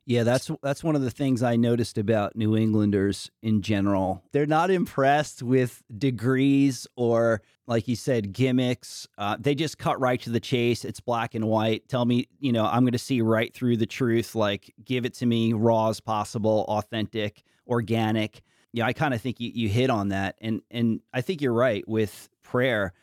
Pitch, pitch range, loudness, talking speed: 120 Hz, 110-130 Hz, -25 LUFS, 200 wpm